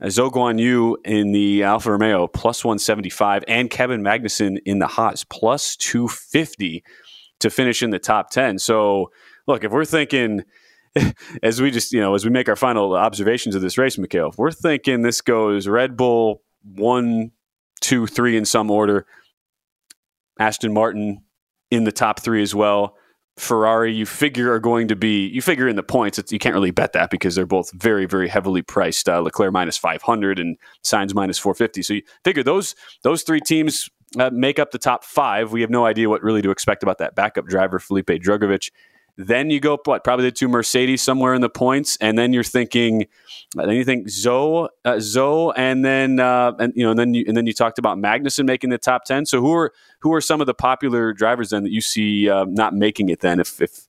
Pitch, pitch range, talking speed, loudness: 115 Hz, 105-125 Hz, 210 wpm, -19 LUFS